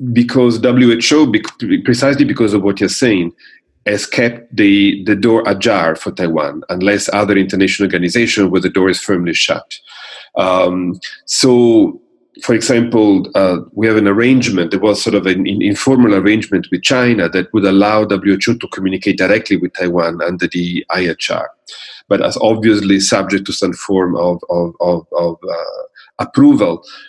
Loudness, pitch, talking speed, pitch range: -13 LUFS, 105 Hz, 155 wpm, 95-125 Hz